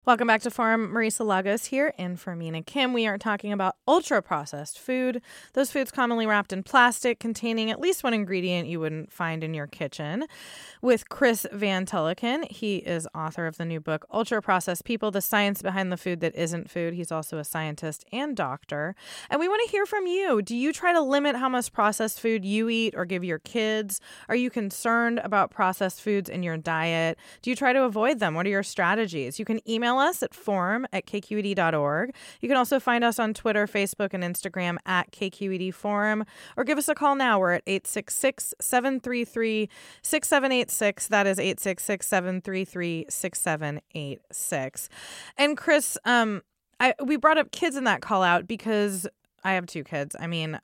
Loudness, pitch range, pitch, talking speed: -26 LUFS, 180-245 Hz, 210 Hz, 185 wpm